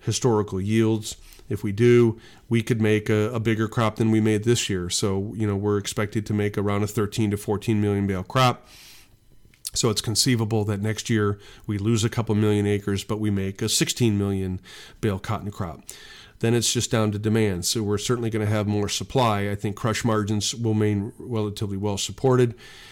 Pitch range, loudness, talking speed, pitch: 105-115 Hz, -24 LUFS, 200 wpm, 105 Hz